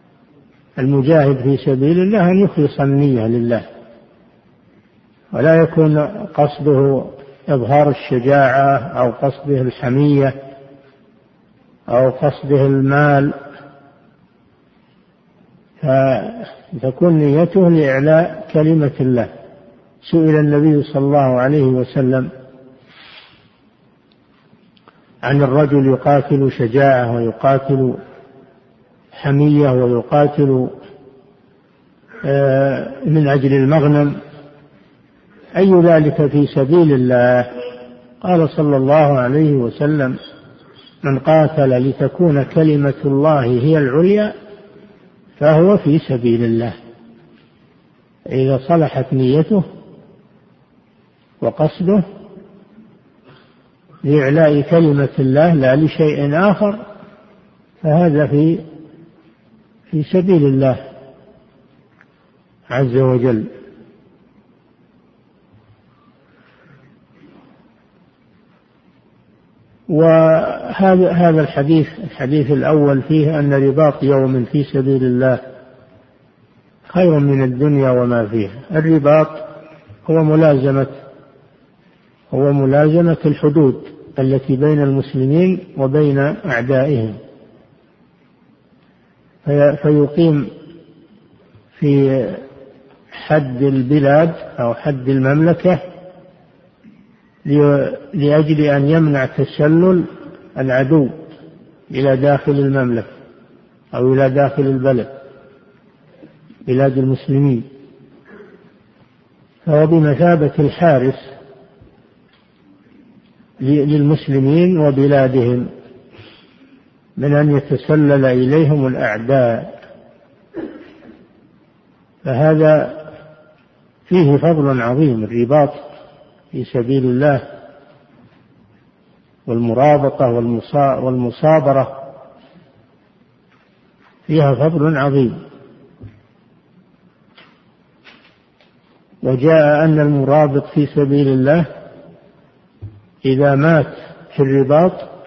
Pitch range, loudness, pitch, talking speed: 135-155 Hz, -14 LUFS, 145 Hz, 65 wpm